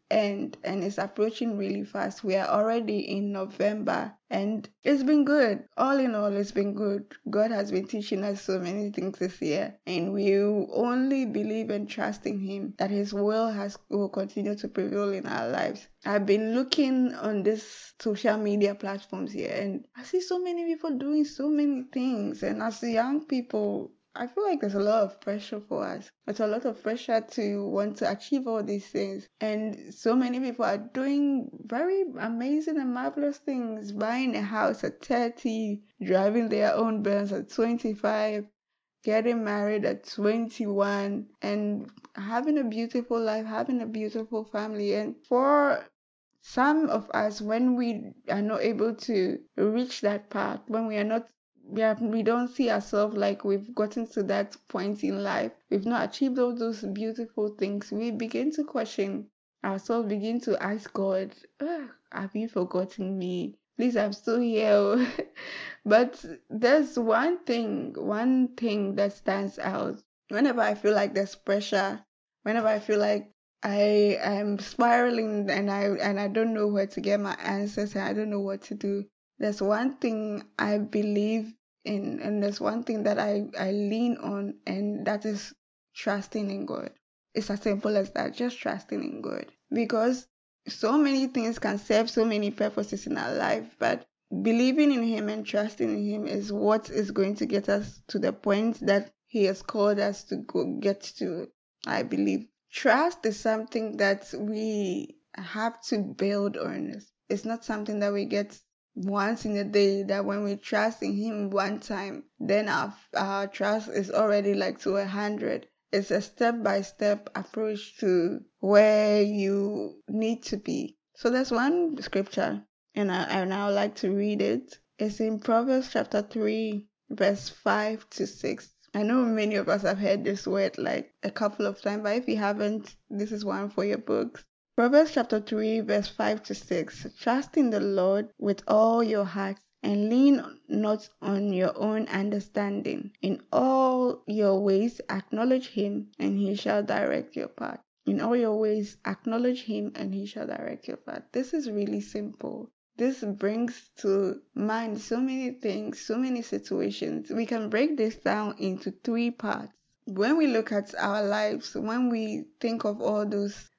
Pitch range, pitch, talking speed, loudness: 200-235 Hz, 215 Hz, 175 wpm, -28 LUFS